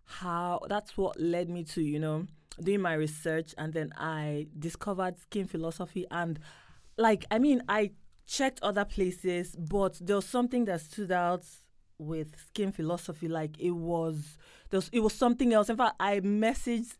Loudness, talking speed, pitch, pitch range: -31 LUFS, 170 wpm, 180 Hz, 165-205 Hz